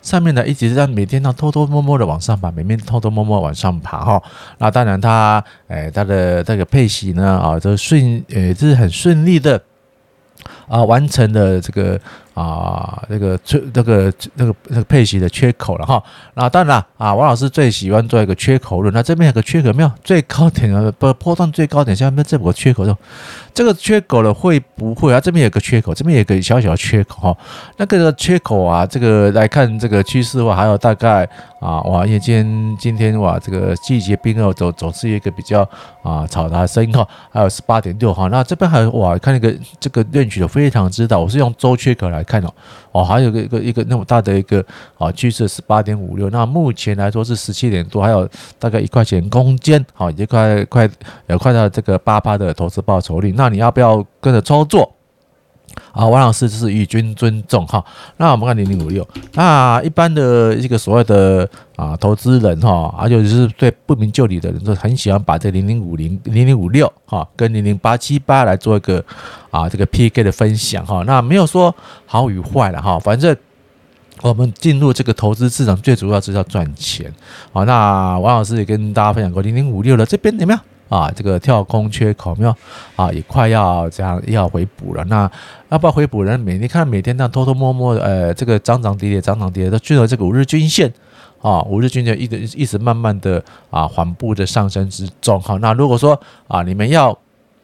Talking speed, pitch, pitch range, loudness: 310 characters per minute, 110 Hz, 100-130 Hz, -14 LUFS